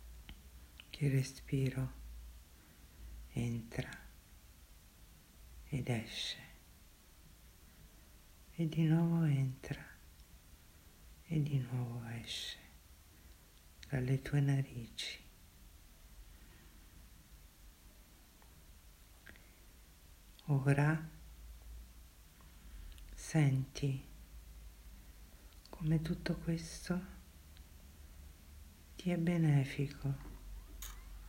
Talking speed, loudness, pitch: 45 wpm, -38 LUFS, 80 Hz